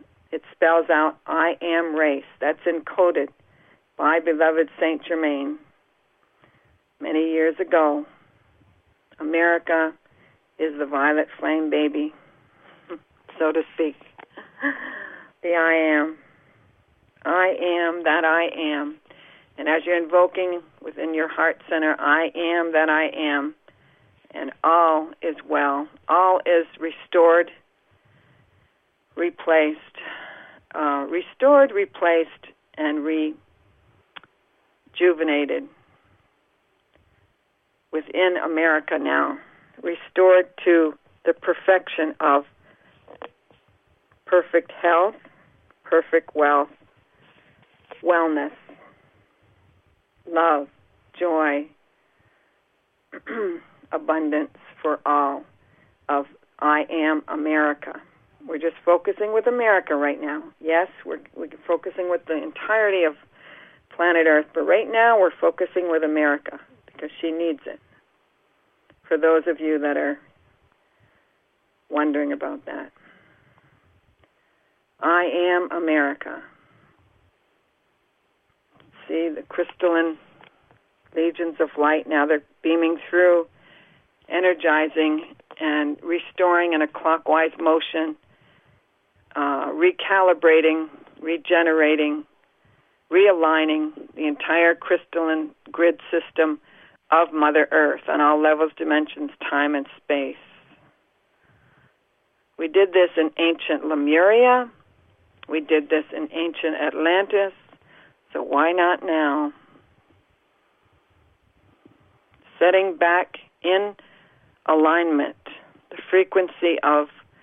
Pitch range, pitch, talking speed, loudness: 150-170 Hz, 160 Hz, 90 wpm, -21 LUFS